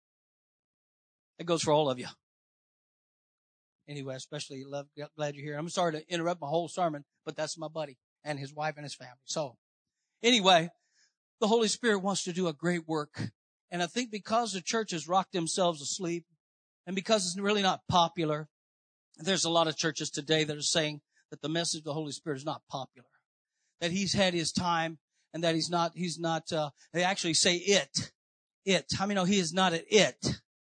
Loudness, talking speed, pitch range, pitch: -30 LUFS, 195 wpm, 150-185 Hz, 165 Hz